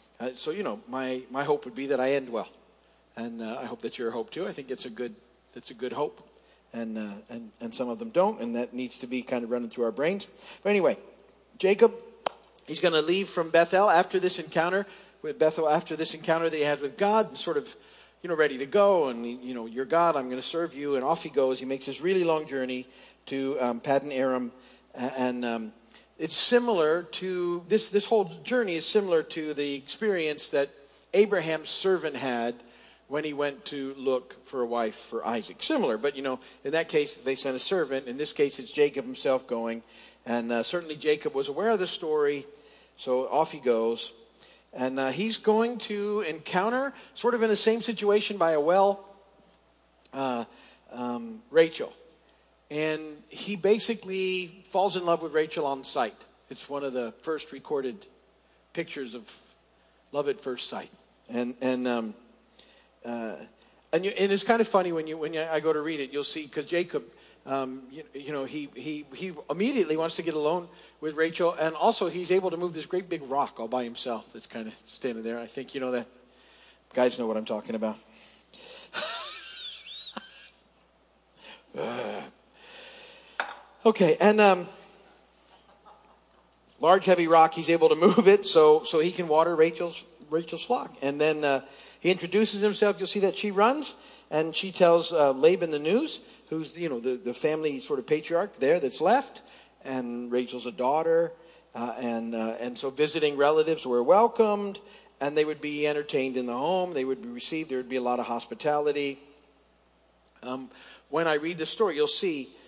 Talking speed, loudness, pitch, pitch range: 190 wpm, -28 LUFS, 150 Hz, 125-180 Hz